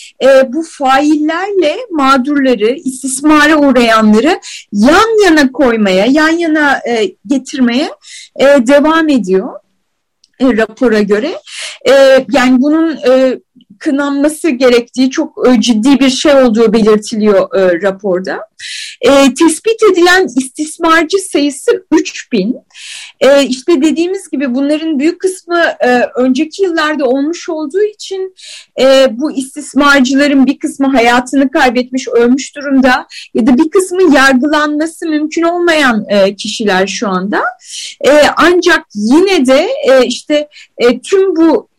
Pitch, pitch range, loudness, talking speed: 280 Hz, 255-325 Hz, -10 LUFS, 115 wpm